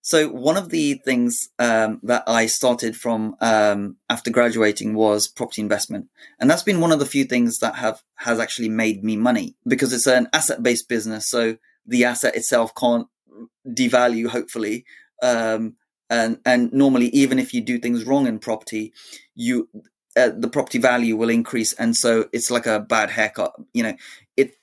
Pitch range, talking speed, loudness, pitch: 115-135 Hz, 175 wpm, -20 LUFS, 120 Hz